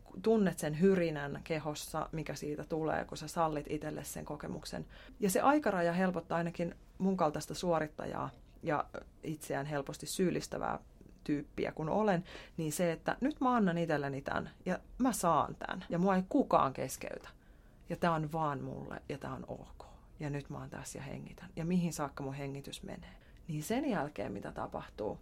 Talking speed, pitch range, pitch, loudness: 170 wpm, 150-190 Hz, 165 Hz, -36 LUFS